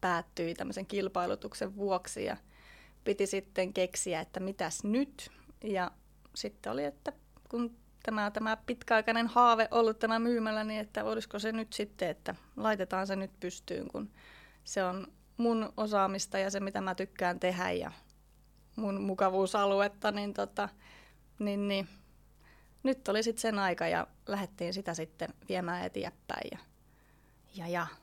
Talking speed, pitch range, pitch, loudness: 140 wpm, 185-220 Hz, 195 Hz, -34 LUFS